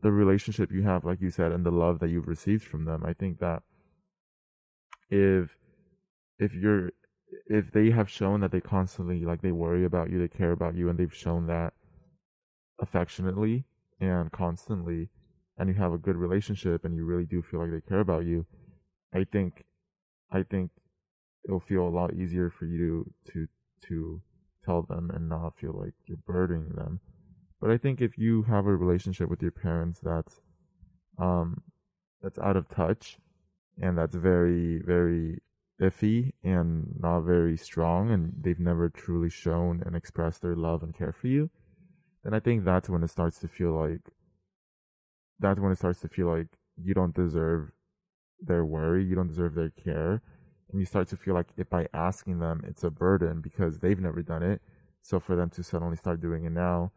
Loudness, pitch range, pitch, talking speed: -29 LUFS, 85-95 Hz, 90 Hz, 185 wpm